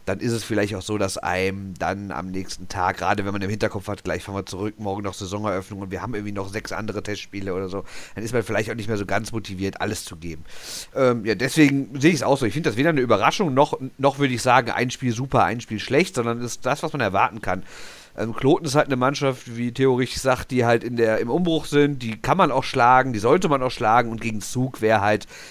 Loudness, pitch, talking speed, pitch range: -22 LUFS, 115 Hz, 265 wpm, 100-130 Hz